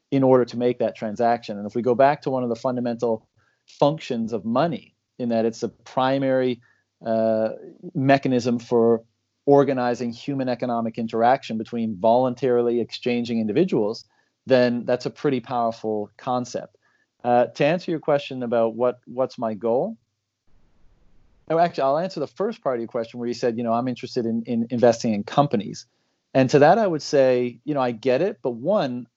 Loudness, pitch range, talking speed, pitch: -23 LUFS, 115-130 Hz, 175 wpm, 120 Hz